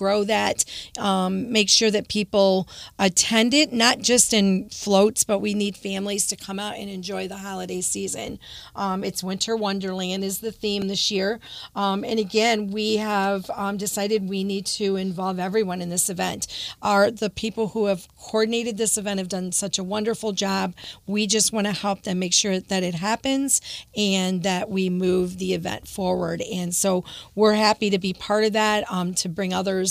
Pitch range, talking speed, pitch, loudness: 190-215 Hz, 190 wpm, 200 Hz, -23 LUFS